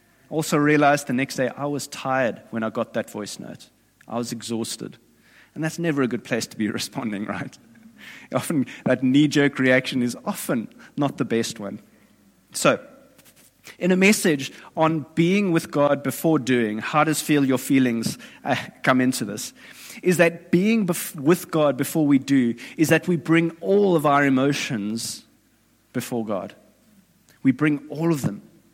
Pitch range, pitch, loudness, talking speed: 130-170 Hz, 145 Hz, -22 LUFS, 170 wpm